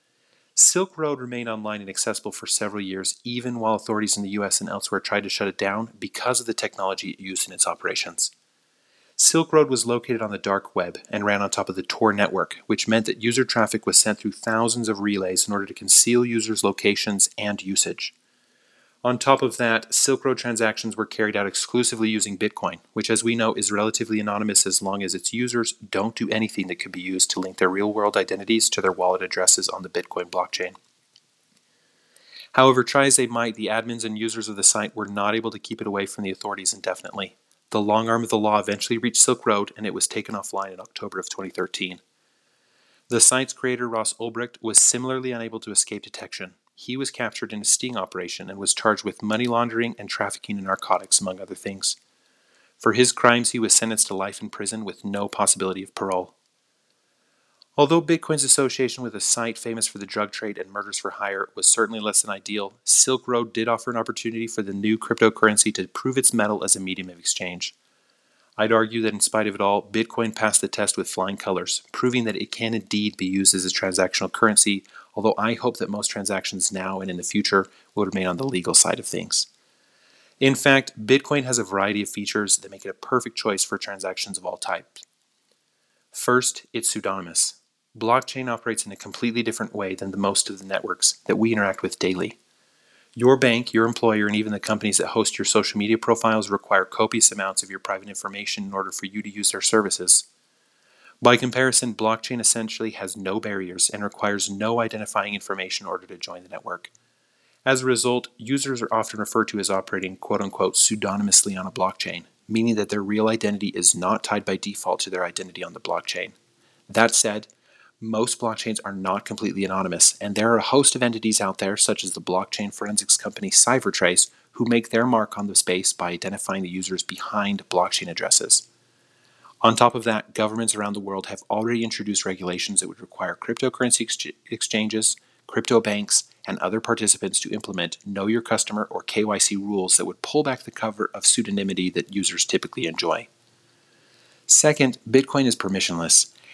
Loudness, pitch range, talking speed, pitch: -21 LUFS, 100-115 Hz, 200 wpm, 110 Hz